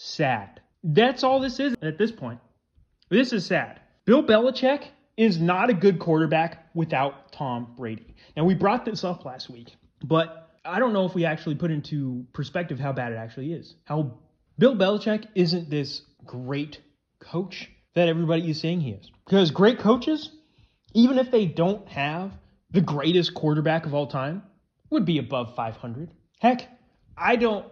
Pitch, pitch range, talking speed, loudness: 165 Hz, 145-210 Hz, 165 wpm, -24 LUFS